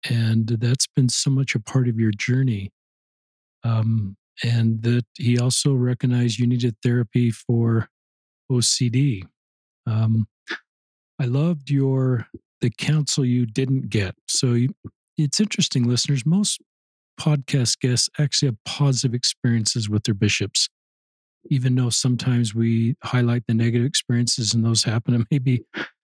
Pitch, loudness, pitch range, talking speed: 120 Hz, -21 LUFS, 115-135 Hz, 135 wpm